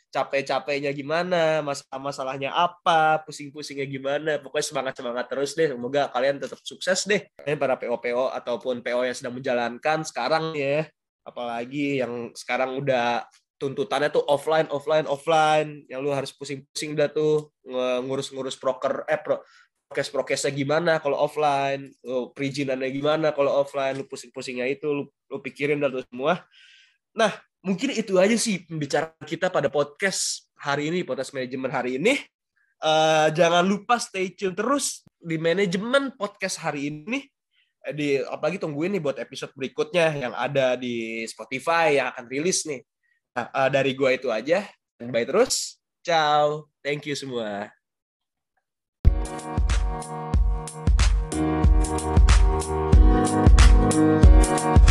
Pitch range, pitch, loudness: 125-155 Hz, 140 Hz, -24 LUFS